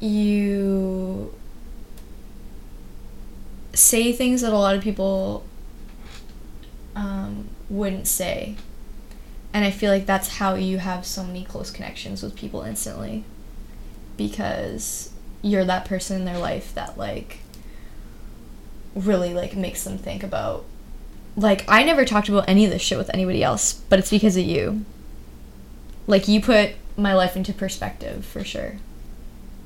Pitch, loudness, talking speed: 190 Hz, -22 LUFS, 135 wpm